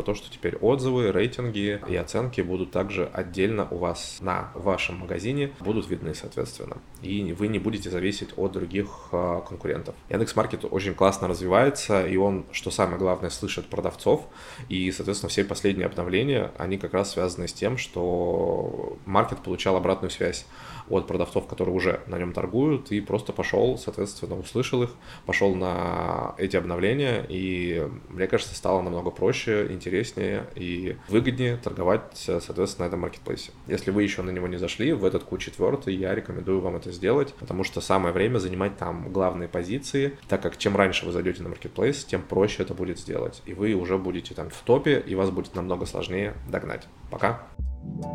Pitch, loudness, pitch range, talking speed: 95 Hz, -27 LUFS, 90-100 Hz, 170 wpm